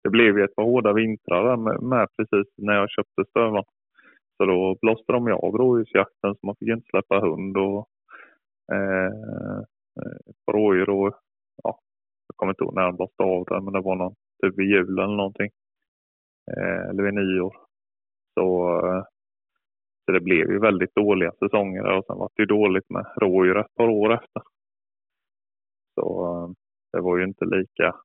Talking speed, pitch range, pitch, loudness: 180 wpm, 90-105 Hz, 95 Hz, -23 LUFS